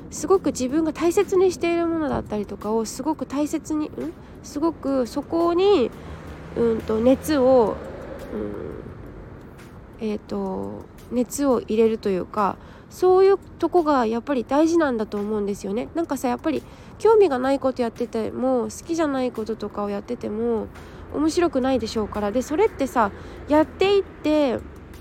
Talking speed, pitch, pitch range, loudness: 325 characters per minute, 260 Hz, 225-320 Hz, -22 LUFS